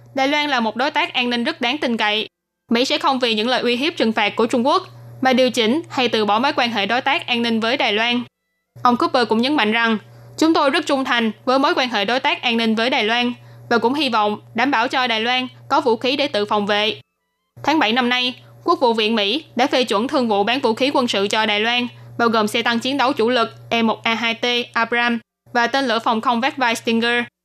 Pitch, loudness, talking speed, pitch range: 240 Hz, -18 LUFS, 265 wpm, 220-260 Hz